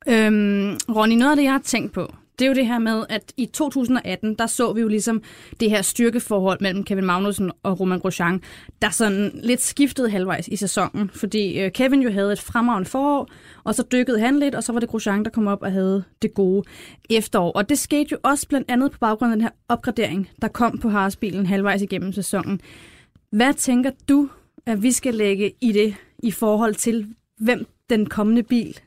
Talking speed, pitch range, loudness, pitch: 210 wpm, 200-245 Hz, -21 LUFS, 220 Hz